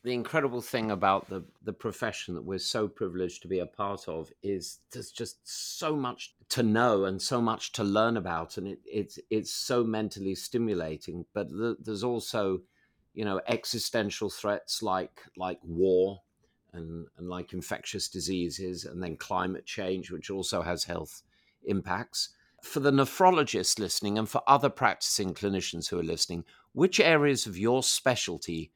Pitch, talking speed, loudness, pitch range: 100 Hz, 165 wpm, -30 LUFS, 90-120 Hz